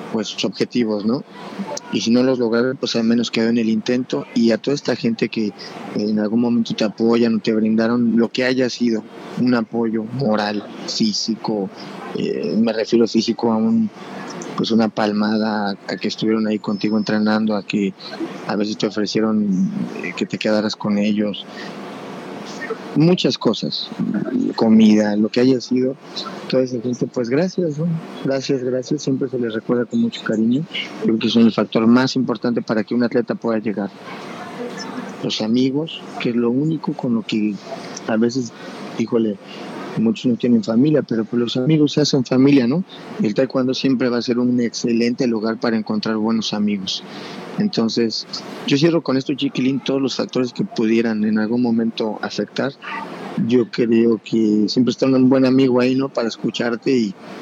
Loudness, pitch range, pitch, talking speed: -19 LUFS, 110-130 Hz, 120 Hz, 170 wpm